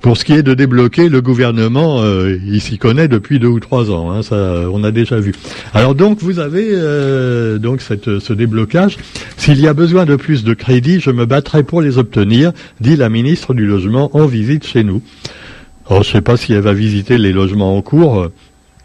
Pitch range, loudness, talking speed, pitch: 105-145 Hz, -12 LUFS, 215 wpm, 120 Hz